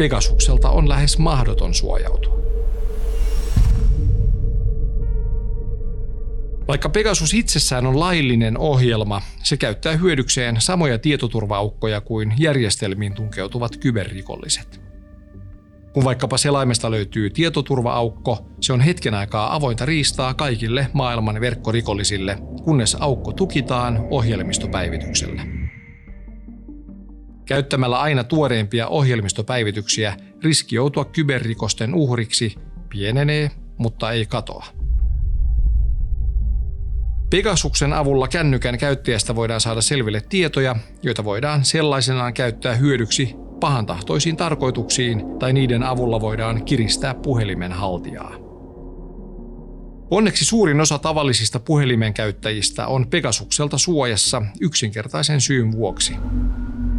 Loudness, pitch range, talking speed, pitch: -20 LUFS, 100-140 Hz, 90 wpm, 115 Hz